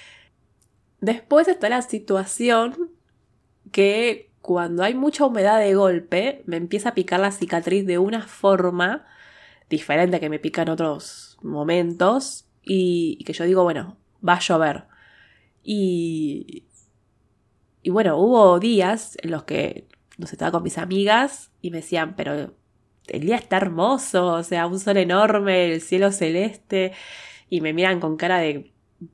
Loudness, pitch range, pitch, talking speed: -21 LUFS, 170-220 Hz, 190 Hz, 150 wpm